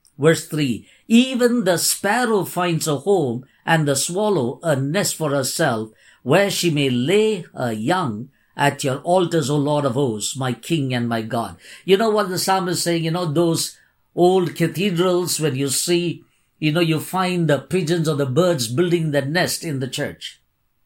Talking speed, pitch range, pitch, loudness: 180 wpm, 140-180 Hz, 160 Hz, -20 LUFS